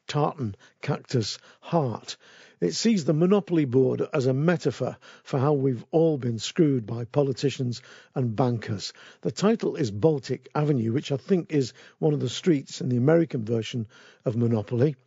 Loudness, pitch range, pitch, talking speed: -26 LUFS, 125-155 Hz, 140 Hz, 160 wpm